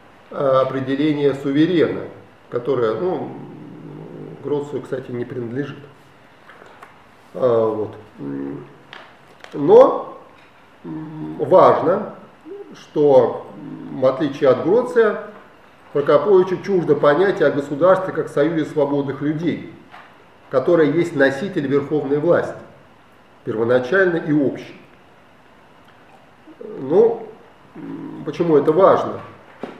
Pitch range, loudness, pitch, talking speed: 135-185 Hz, -18 LUFS, 145 Hz, 75 wpm